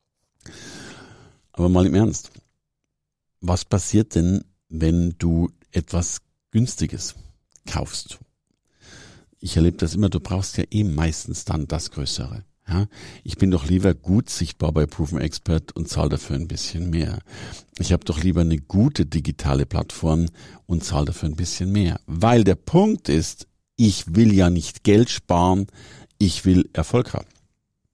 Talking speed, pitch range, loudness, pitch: 145 wpm, 80-100 Hz, -22 LUFS, 90 Hz